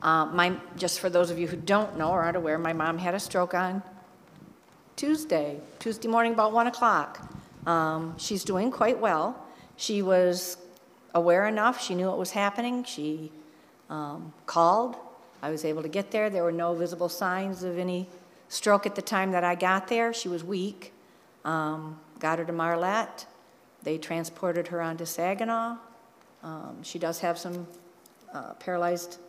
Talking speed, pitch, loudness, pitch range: 170 wpm, 180 Hz, -28 LUFS, 170-200 Hz